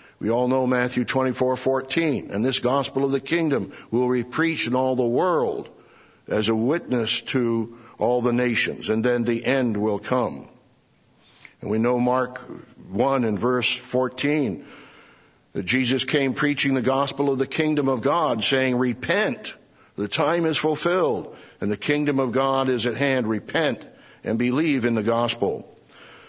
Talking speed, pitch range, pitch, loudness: 160 wpm, 120-135 Hz, 125 Hz, -23 LUFS